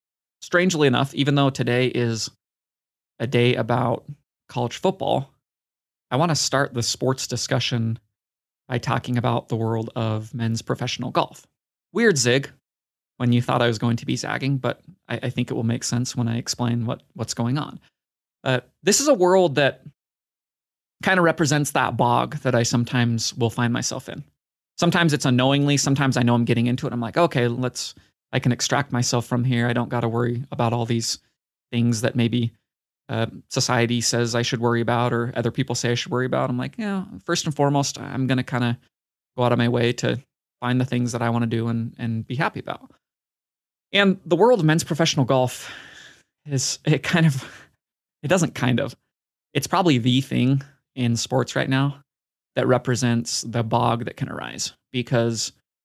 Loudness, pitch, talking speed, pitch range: -22 LUFS, 125 Hz, 195 wpm, 120-140 Hz